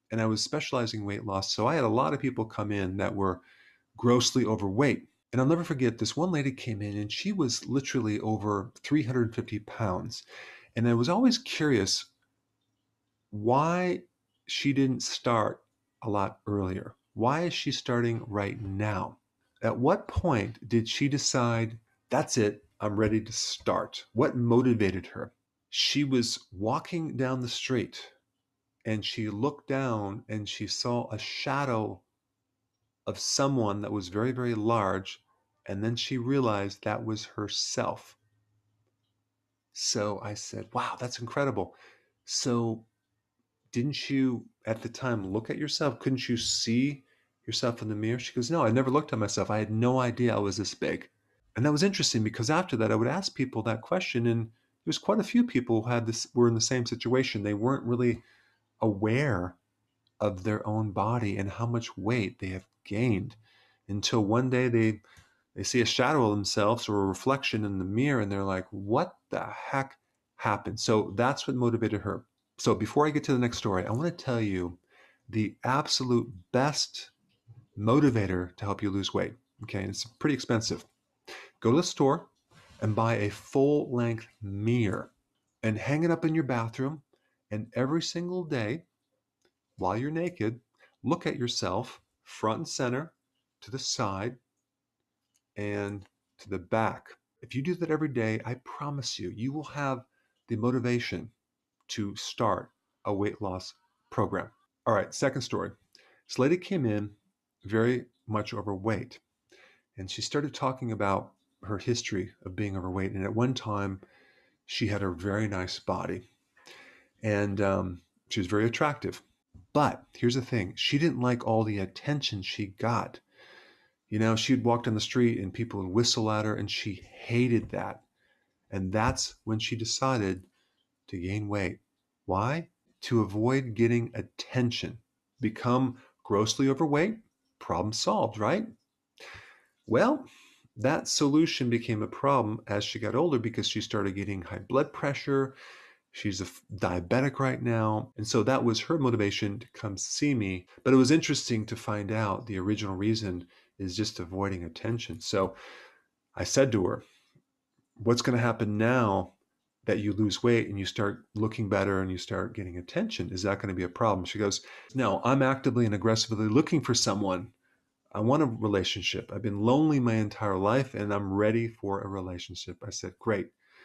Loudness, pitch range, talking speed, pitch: -29 LUFS, 105-130 Hz, 165 wpm, 115 Hz